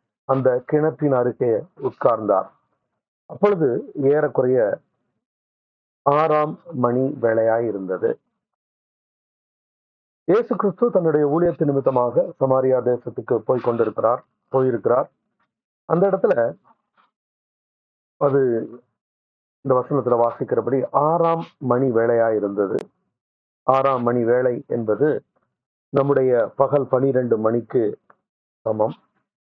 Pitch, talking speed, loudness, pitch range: 130 Hz, 80 wpm, -20 LUFS, 120-150 Hz